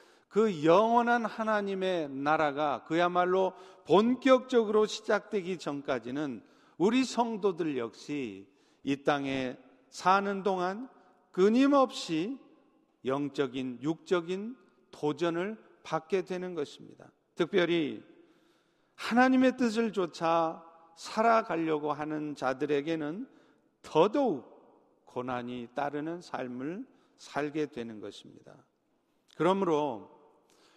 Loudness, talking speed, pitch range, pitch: -30 LUFS, 215 characters per minute, 150-225 Hz, 180 Hz